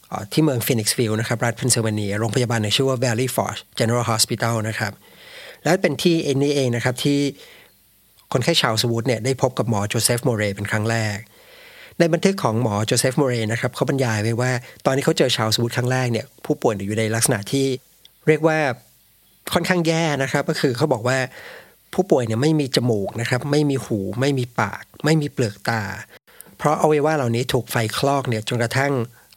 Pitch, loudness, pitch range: 125 Hz, -21 LUFS, 115-145 Hz